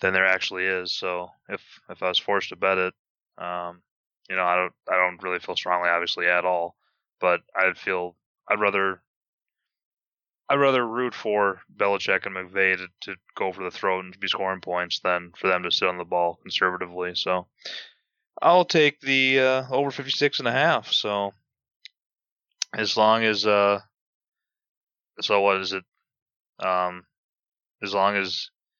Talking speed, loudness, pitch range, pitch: 170 wpm, -24 LUFS, 90-105 Hz, 95 Hz